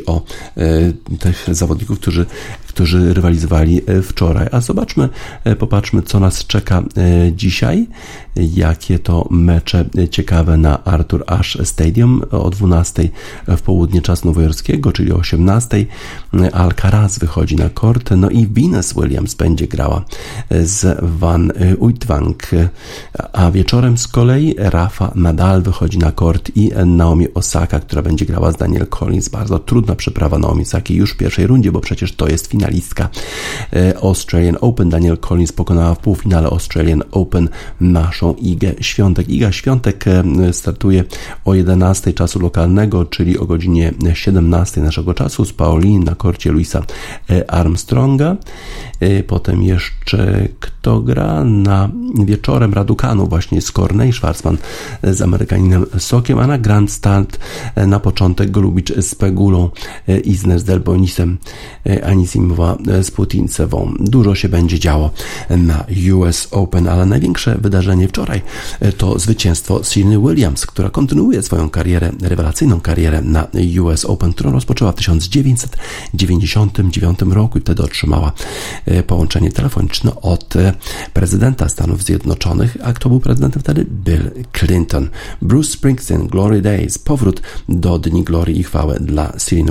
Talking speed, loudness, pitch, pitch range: 130 wpm, -14 LUFS, 95 Hz, 85-105 Hz